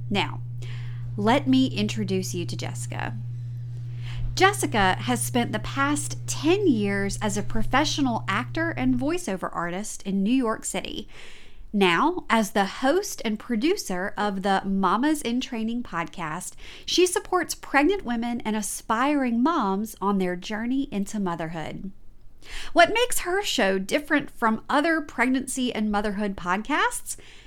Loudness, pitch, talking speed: -25 LUFS, 200 Hz, 130 wpm